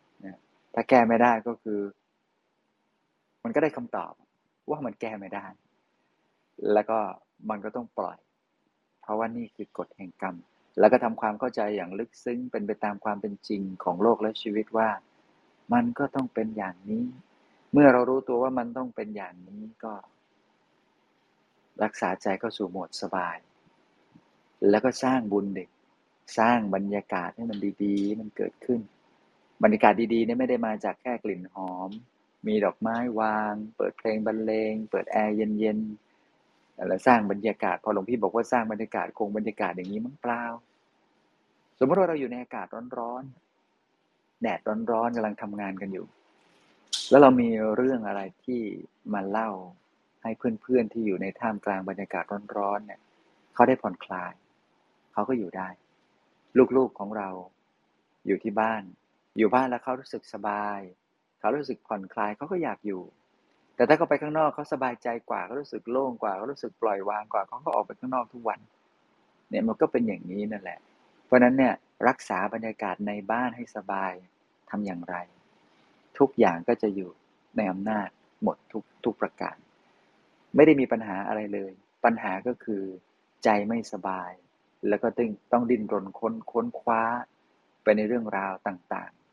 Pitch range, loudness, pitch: 100-120 Hz, -27 LUFS, 110 Hz